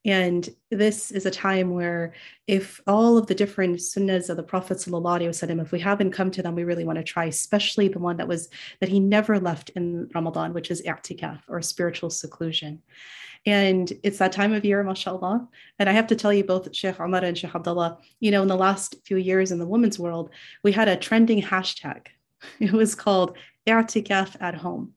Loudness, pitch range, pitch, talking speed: -24 LUFS, 175-200 Hz, 185 Hz, 200 wpm